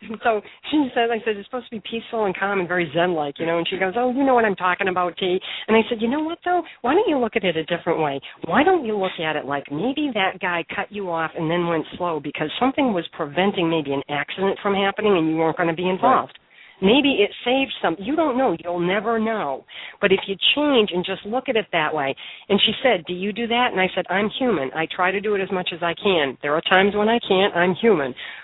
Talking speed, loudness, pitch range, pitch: 270 wpm, -21 LUFS, 175-235 Hz, 195 Hz